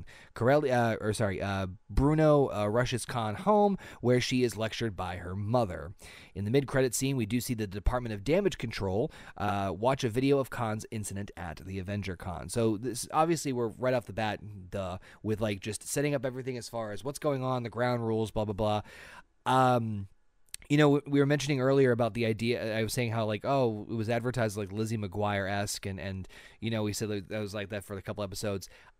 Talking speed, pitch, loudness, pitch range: 215 wpm, 110 Hz, -31 LUFS, 100-125 Hz